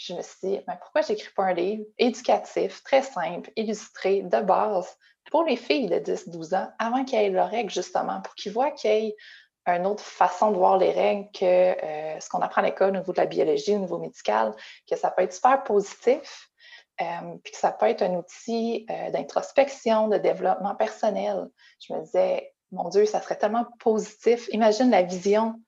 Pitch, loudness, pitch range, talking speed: 215 Hz, -25 LUFS, 195-245 Hz, 205 wpm